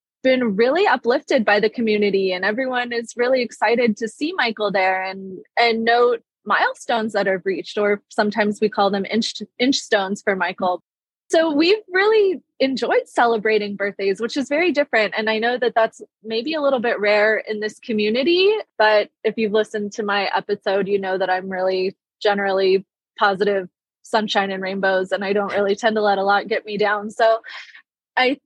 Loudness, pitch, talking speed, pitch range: -20 LUFS, 215 Hz, 185 wpm, 200-245 Hz